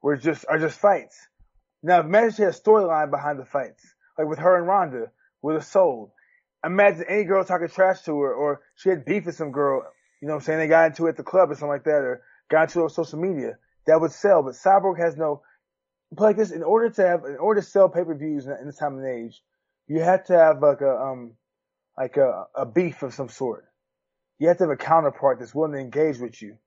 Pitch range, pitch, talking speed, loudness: 145-185 Hz, 160 Hz, 245 wpm, -22 LUFS